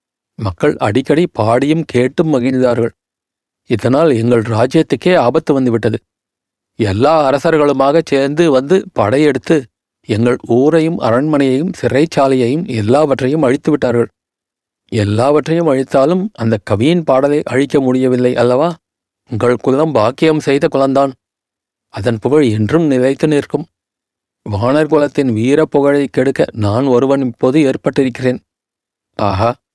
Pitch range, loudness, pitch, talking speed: 120-150 Hz, -13 LUFS, 135 Hz, 100 wpm